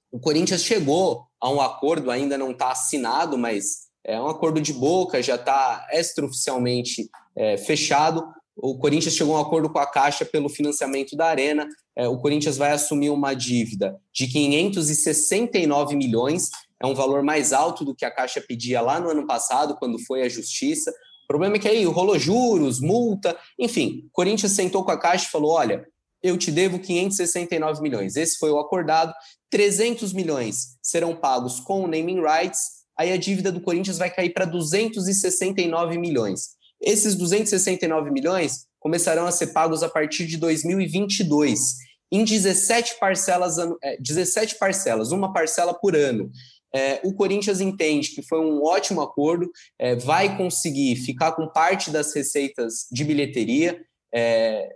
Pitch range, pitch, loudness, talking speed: 145-185 Hz, 160 Hz, -22 LUFS, 160 wpm